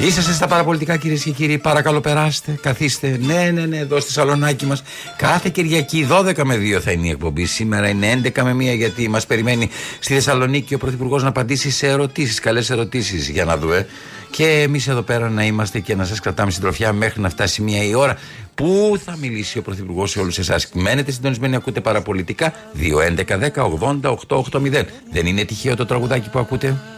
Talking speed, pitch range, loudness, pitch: 200 wpm, 110-150 Hz, -18 LUFS, 130 Hz